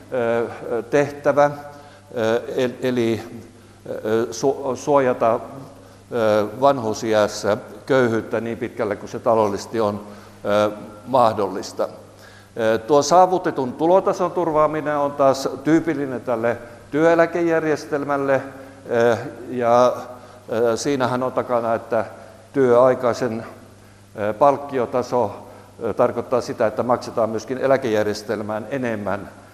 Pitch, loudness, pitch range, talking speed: 120 Hz, -20 LUFS, 110-140 Hz, 70 wpm